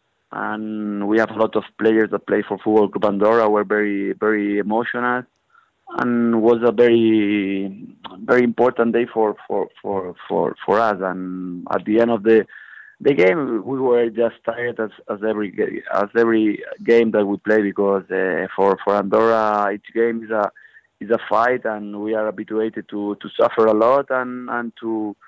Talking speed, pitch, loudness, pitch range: 175 wpm, 110 Hz, -19 LUFS, 105-115 Hz